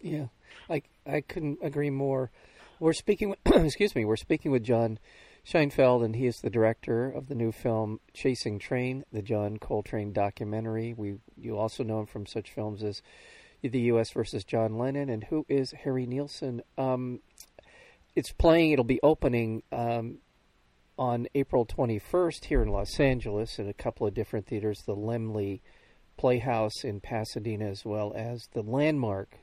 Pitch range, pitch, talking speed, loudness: 110-135 Hz, 115 Hz, 165 wpm, -30 LUFS